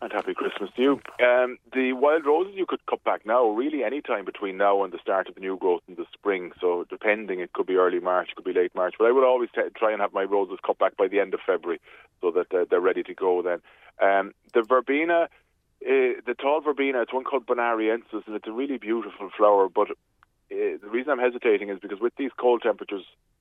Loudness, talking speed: -25 LUFS, 245 wpm